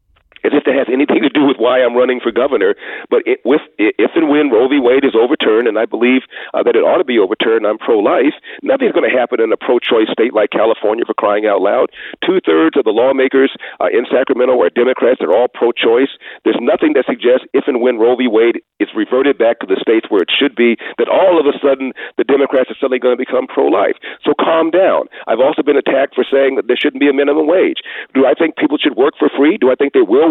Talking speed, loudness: 245 wpm, -13 LUFS